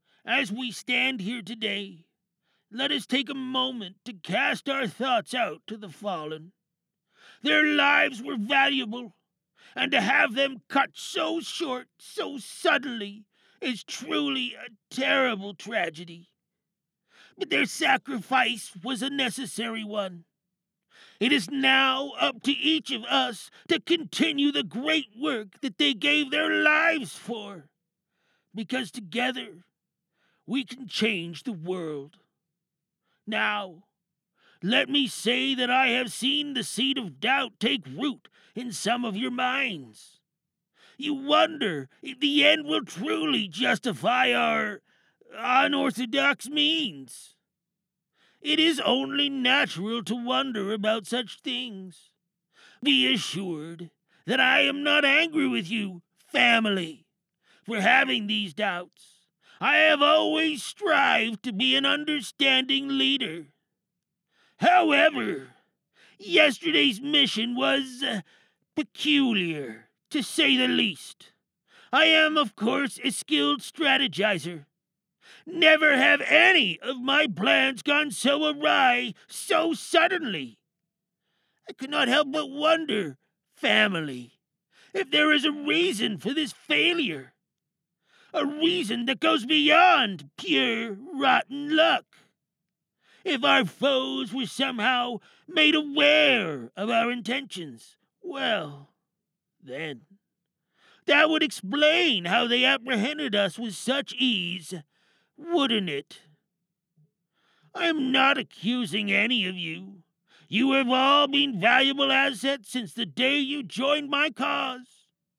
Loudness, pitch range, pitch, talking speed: -24 LUFS, 195-285 Hz, 250 Hz, 120 wpm